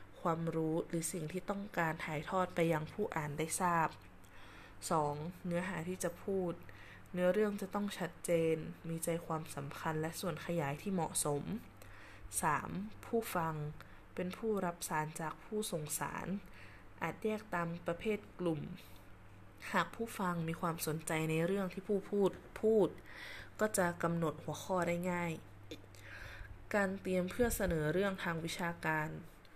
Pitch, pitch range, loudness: 170 Hz, 155-185 Hz, -38 LUFS